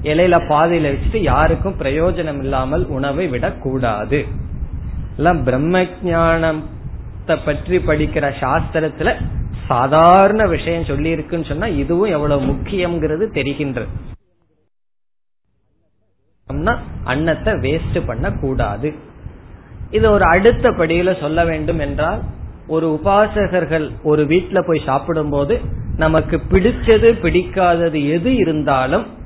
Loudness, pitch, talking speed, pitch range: -16 LUFS, 155 Hz, 90 wpm, 135-170 Hz